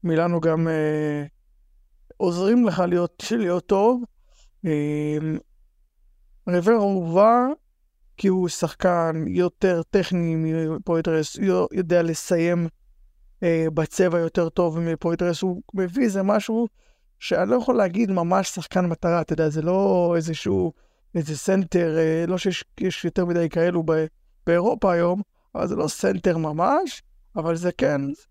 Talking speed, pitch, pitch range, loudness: 125 wpm, 170 Hz, 160-190 Hz, -23 LUFS